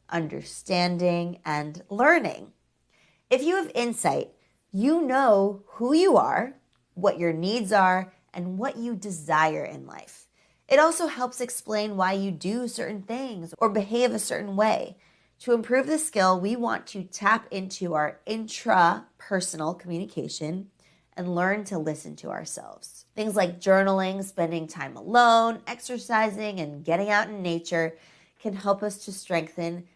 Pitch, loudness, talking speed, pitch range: 200 Hz, -25 LUFS, 140 wpm, 175-230 Hz